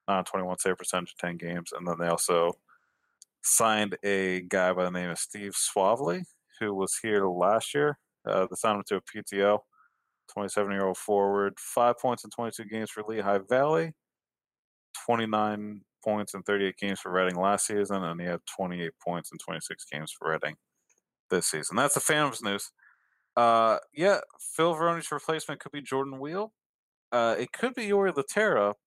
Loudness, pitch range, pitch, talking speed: -28 LUFS, 95-120 Hz, 105 Hz, 180 wpm